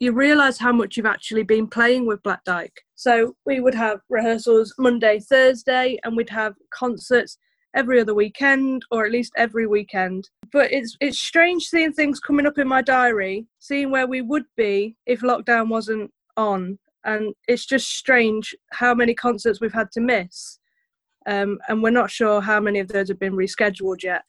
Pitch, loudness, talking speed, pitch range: 235 Hz, -20 LUFS, 185 wpm, 215-265 Hz